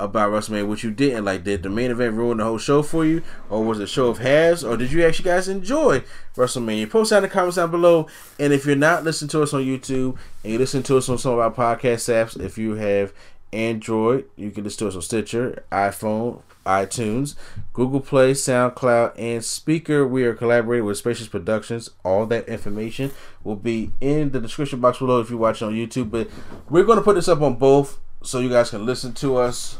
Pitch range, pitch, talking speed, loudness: 110-140 Hz, 120 Hz, 225 wpm, -21 LUFS